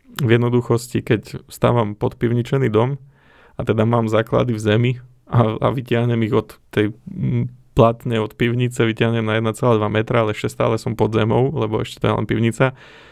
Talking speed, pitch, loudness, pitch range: 170 wpm, 115 Hz, -19 LUFS, 110-125 Hz